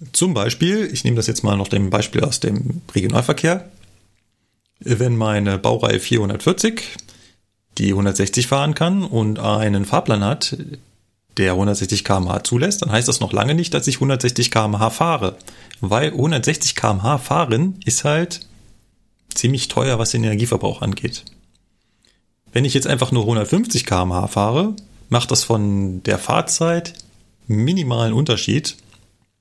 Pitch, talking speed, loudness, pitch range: 115 Hz, 135 wpm, -18 LUFS, 100-140 Hz